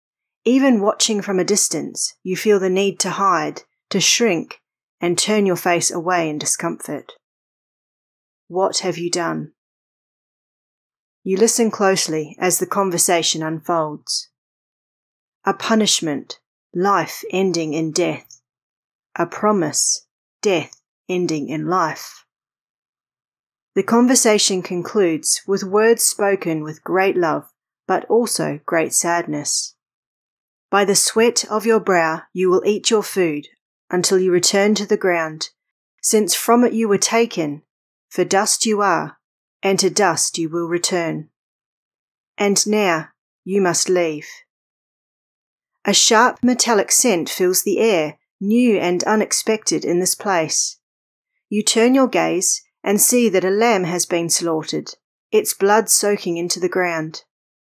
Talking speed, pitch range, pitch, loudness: 130 wpm, 170-210 Hz, 185 Hz, -18 LUFS